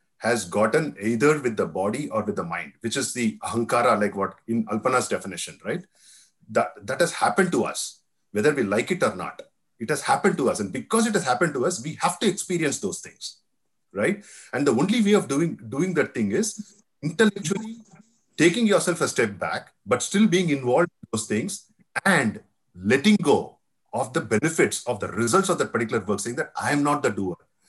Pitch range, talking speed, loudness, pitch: 125-205 Hz, 205 wpm, -24 LUFS, 170 Hz